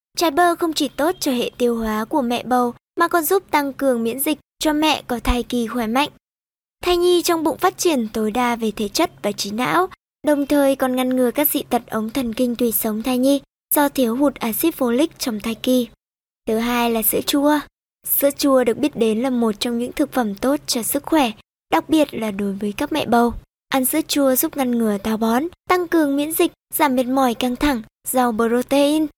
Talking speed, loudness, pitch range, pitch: 225 wpm, -19 LUFS, 235-300 Hz, 260 Hz